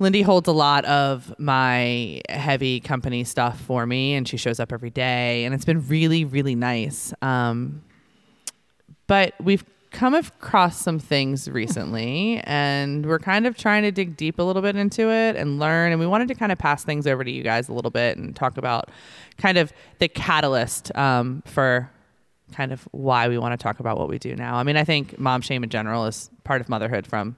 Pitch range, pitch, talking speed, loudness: 125-165 Hz, 140 Hz, 210 wpm, -22 LUFS